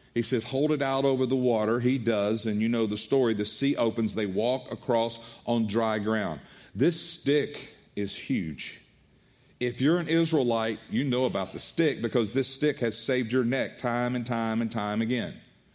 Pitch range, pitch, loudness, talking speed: 115-130 Hz, 120 Hz, -28 LUFS, 190 wpm